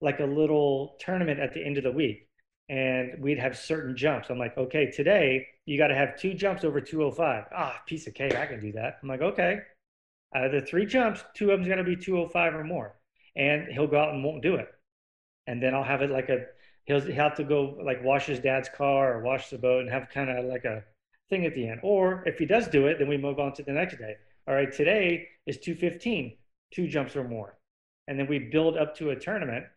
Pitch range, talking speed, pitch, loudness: 130-160 Hz, 245 wpm, 140 Hz, -28 LUFS